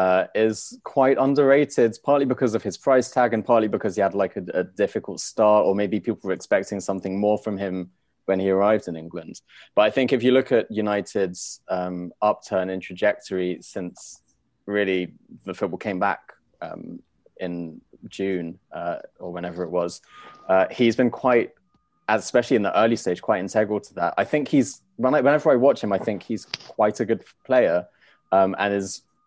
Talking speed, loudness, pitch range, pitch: 185 wpm, -23 LUFS, 95-115 Hz, 105 Hz